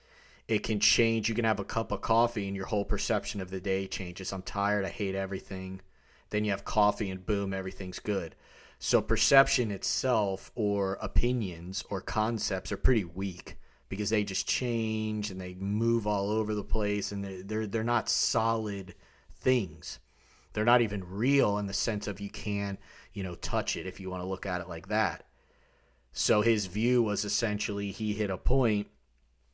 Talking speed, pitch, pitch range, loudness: 185 wpm, 100 Hz, 95-110 Hz, -30 LUFS